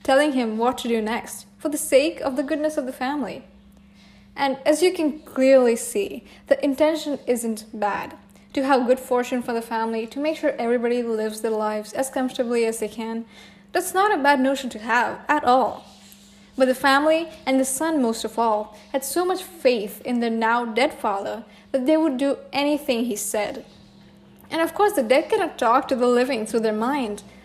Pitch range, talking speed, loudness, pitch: 225-285 Hz, 200 wpm, -22 LUFS, 255 Hz